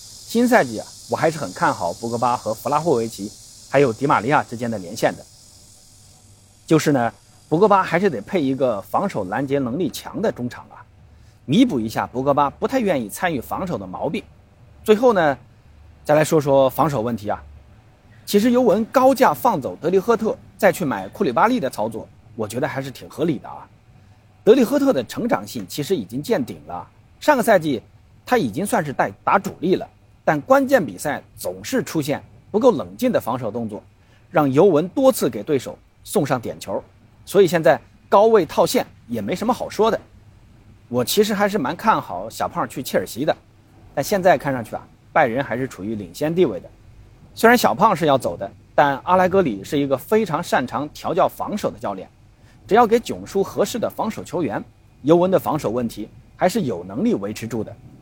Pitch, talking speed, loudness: 135 Hz, 285 characters per minute, -20 LUFS